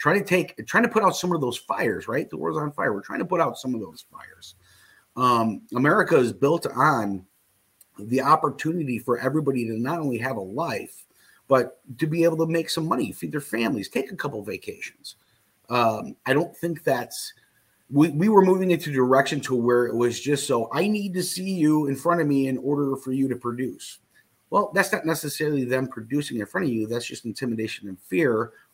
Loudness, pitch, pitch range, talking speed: -24 LUFS, 135 Hz, 120-165 Hz, 215 wpm